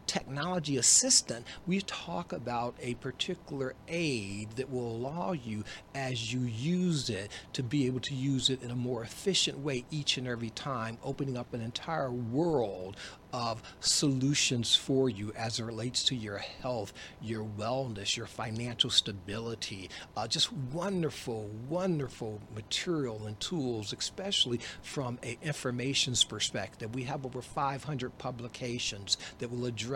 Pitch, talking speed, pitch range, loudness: 125 Hz, 140 wpm, 115-140 Hz, -32 LUFS